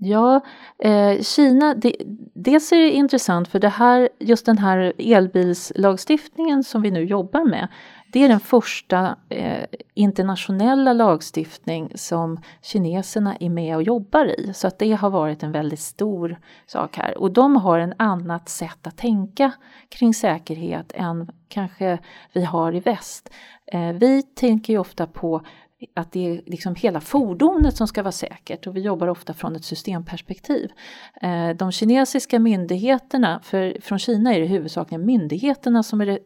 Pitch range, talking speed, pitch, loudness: 175-245 Hz, 155 wpm, 200 Hz, -20 LUFS